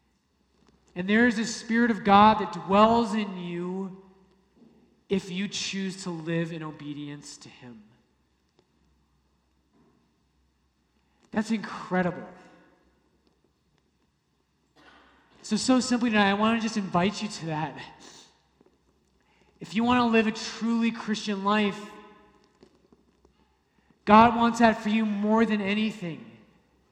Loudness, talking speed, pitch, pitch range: -25 LUFS, 115 wpm, 200 Hz, 170-220 Hz